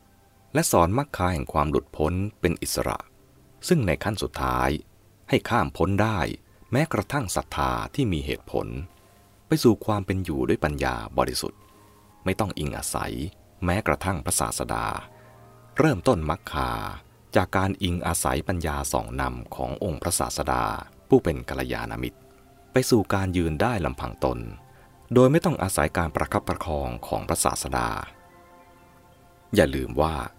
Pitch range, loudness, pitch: 75-100 Hz, -25 LUFS, 90 Hz